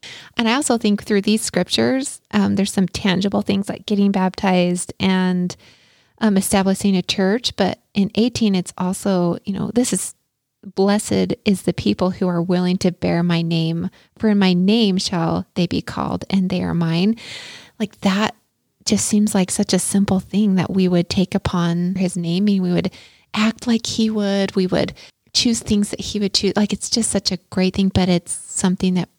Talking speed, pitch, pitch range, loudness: 195 wpm, 195 Hz, 180-210 Hz, -19 LUFS